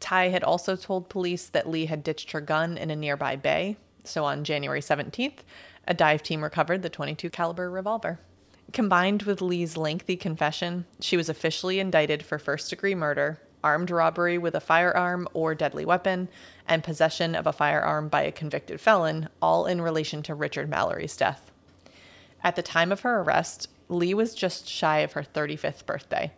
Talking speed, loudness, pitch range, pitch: 180 wpm, -27 LUFS, 155-180 Hz, 165 Hz